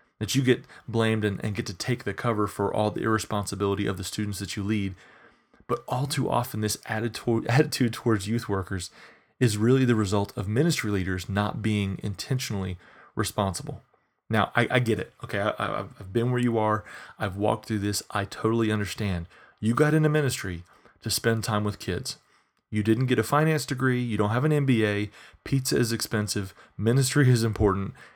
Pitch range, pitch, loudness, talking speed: 105-125 Hz, 110 Hz, -26 LUFS, 185 wpm